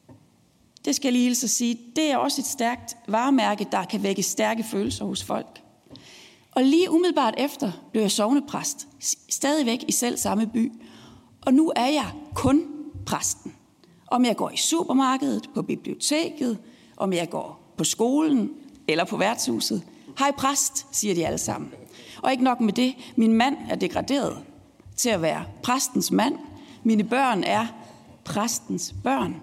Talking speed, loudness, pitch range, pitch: 155 wpm, -24 LUFS, 220-275 Hz, 245 Hz